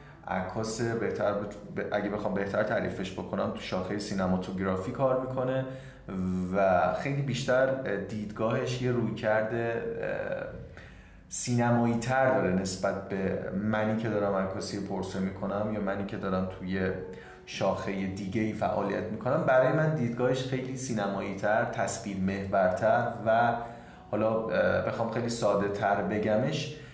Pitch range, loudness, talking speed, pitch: 95-120 Hz, -30 LUFS, 125 wpm, 105 Hz